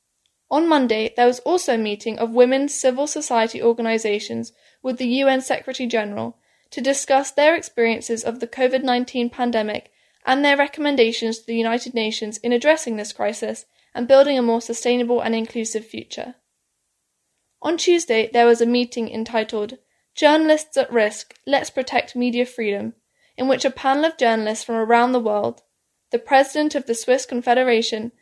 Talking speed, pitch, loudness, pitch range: 155 wpm, 245 Hz, -20 LUFS, 225-270 Hz